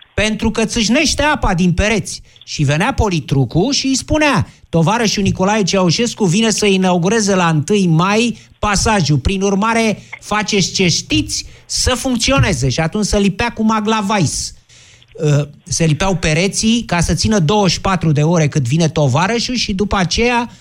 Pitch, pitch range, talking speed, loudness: 195 Hz, 160-220 Hz, 145 wpm, -15 LUFS